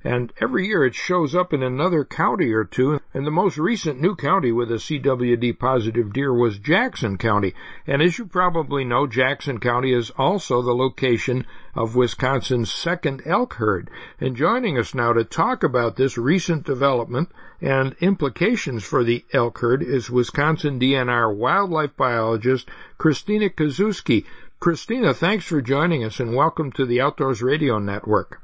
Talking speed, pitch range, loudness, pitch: 160 wpm, 120-165 Hz, -21 LUFS, 135 Hz